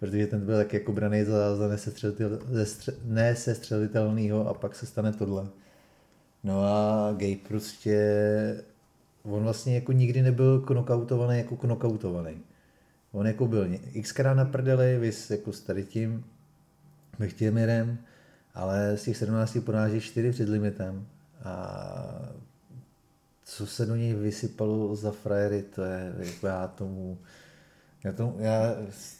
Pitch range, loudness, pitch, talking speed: 105-120 Hz, -28 LUFS, 110 Hz, 130 wpm